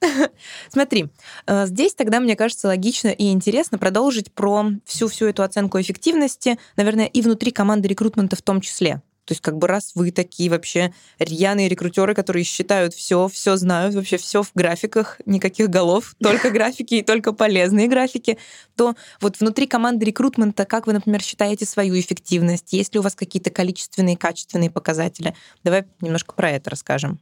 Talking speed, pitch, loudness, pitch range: 160 wpm, 200 Hz, -20 LUFS, 185-220 Hz